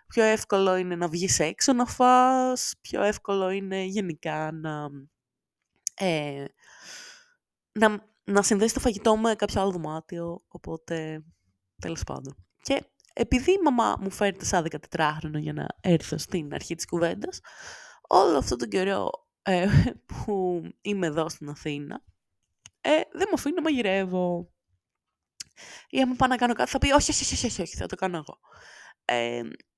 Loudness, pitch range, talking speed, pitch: -26 LUFS, 155-235 Hz, 155 wpm, 190 Hz